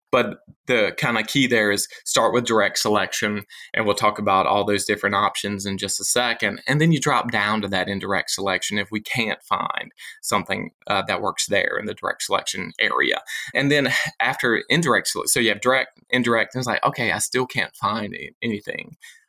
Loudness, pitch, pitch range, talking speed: -21 LUFS, 110 Hz, 100-125 Hz, 200 wpm